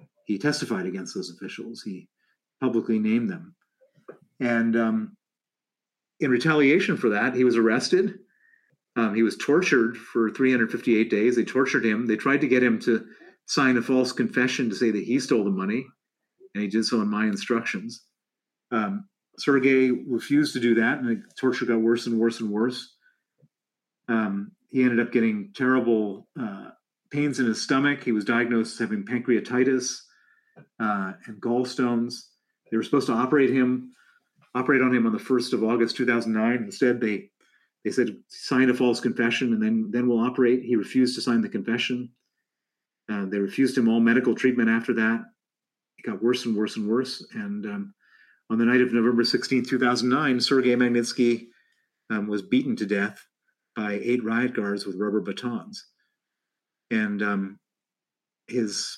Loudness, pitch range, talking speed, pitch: -24 LUFS, 115-135 Hz, 170 wpm, 125 Hz